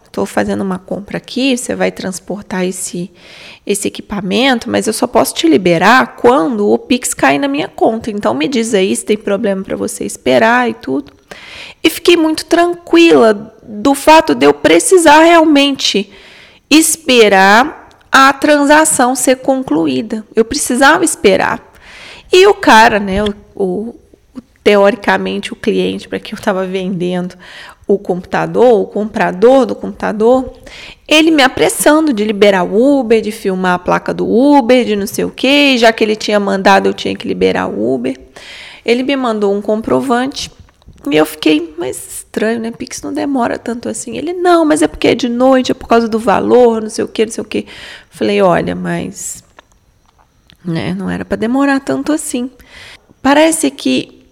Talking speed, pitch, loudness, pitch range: 170 wpm, 230 Hz, -11 LUFS, 195-275 Hz